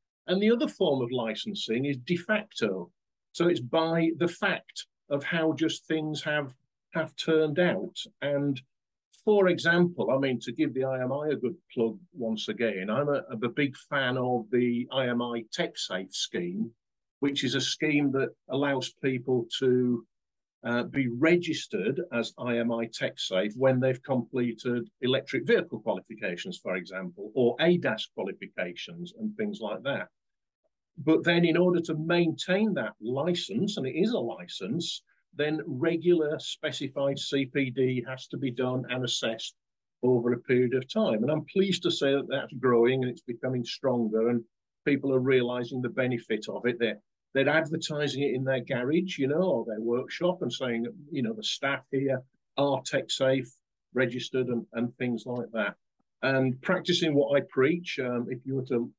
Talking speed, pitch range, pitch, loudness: 165 wpm, 125-160 Hz, 135 Hz, -29 LUFS